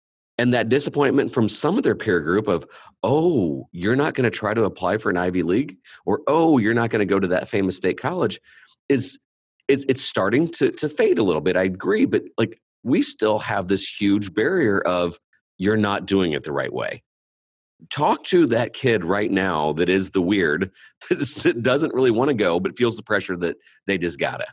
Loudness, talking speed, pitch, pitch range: -21 LUFS, 215 wpm, 100 Hz, 95-120 Hz